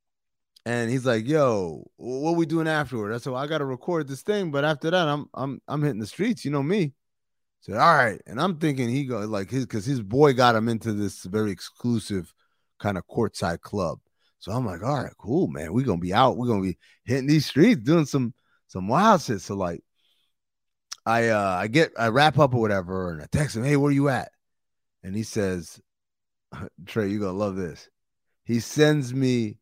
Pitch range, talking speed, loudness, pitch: 105-145 Hz, 215 wpm, -24 LUFS, 120 Hz